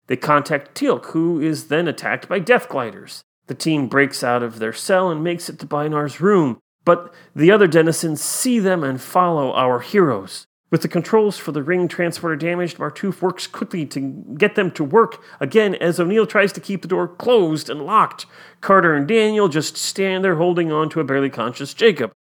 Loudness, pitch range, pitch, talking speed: -18 LUFS, 150-190 Hz, 170 Hz, 195 wpm